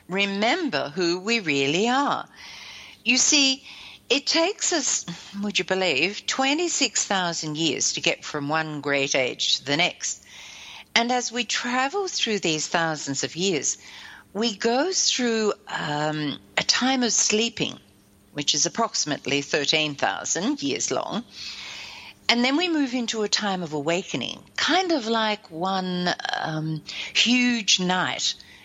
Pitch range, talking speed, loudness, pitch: 165-250 Hz, 130 wpm, -23 LUFS, 205 Hz